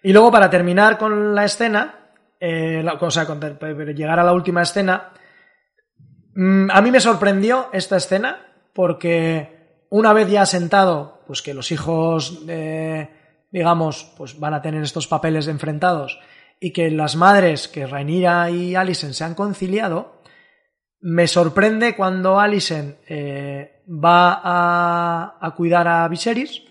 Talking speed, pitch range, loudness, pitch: 155 wpm, 160-195 Hz, -17 LUFS, 175 Hz